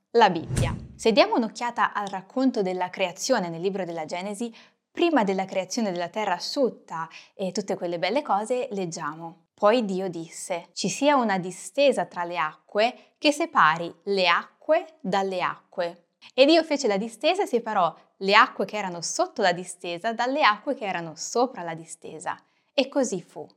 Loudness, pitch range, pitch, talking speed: -25 LUFS, 175-245 Hz, 195 Hz, 165 wpm